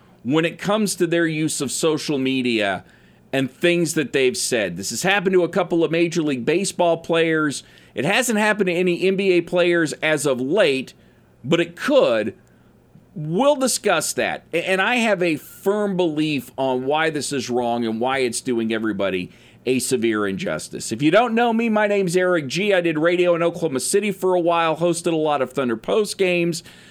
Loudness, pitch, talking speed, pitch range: -20 LUFS, 170 Hz, 190 wpm, 135-185 Hz